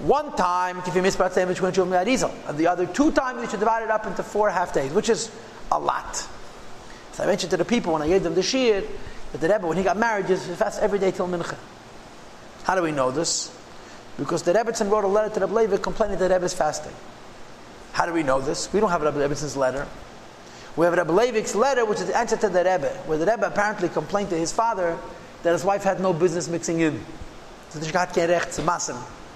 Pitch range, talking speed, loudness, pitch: 170-215 Hz, 220 wpm, -23 LUFS, 185 Hz